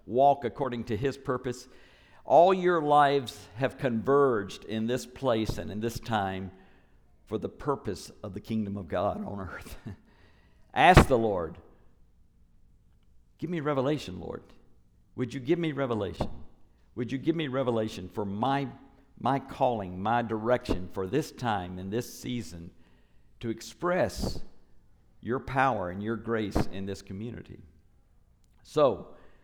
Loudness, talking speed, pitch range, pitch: -29 LUFS, 135 wpm, 95-130 Hz, 115 Hz